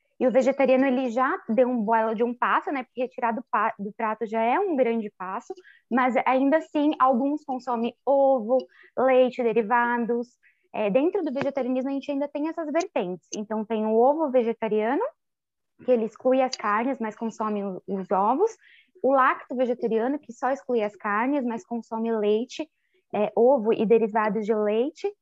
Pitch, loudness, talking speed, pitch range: 250 Hz, -25 LUFS, 165 wpm, 225-275 Hz